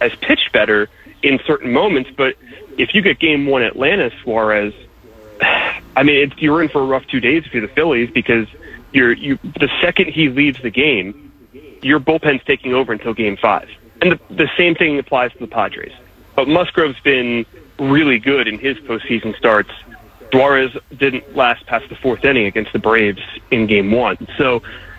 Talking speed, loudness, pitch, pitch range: 185 wpm, -15 LUFS, 130 Hz, 115-150 Hz